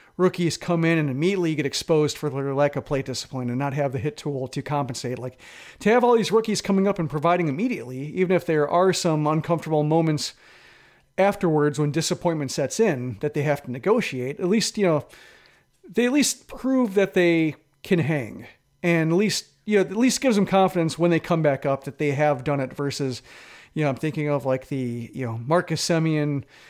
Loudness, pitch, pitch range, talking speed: -23 LUFS, 155 Hz, 140-185 Hz, 210 wpm